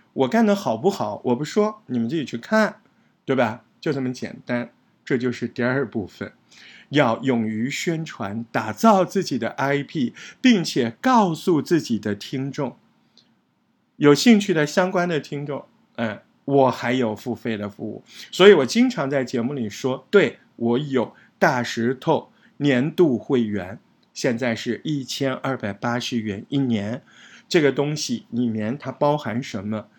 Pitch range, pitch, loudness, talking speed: 120-160 Hz, 130 Hz, -22 LUFS, 225 characters per minute